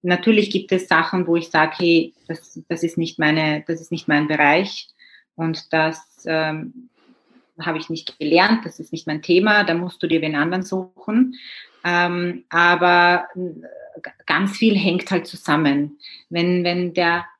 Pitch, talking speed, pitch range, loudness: 170 Hz, 160 wpm, 160-185 Hz, -19 LUFS